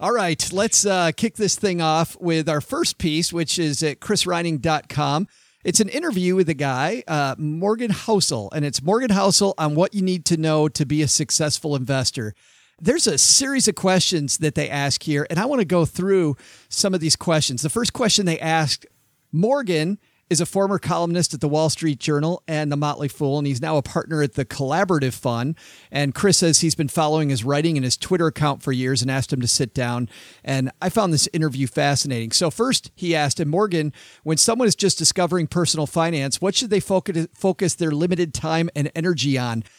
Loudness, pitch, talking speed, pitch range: -20 LUFS, 160 Hz, 205 wpm, 145-185 Hz